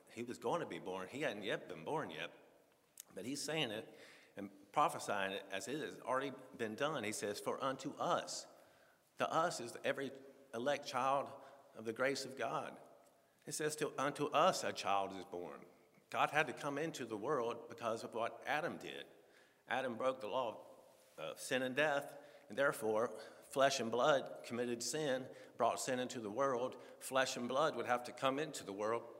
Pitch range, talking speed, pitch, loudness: 110-145 Hz, 190 wpm, 130 Hz, -40 LUFS